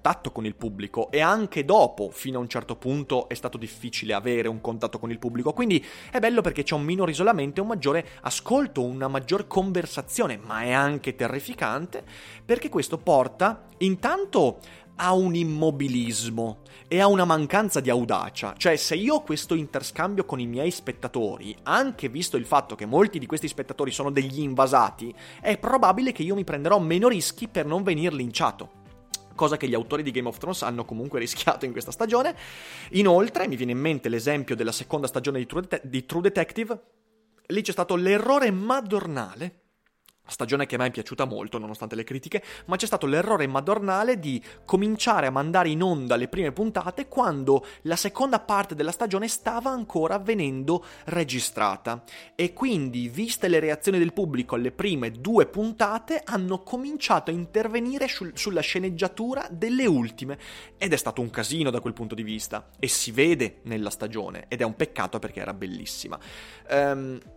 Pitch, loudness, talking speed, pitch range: 160 Hz, -26 LUFS, 175 wpm, 125-200 Hz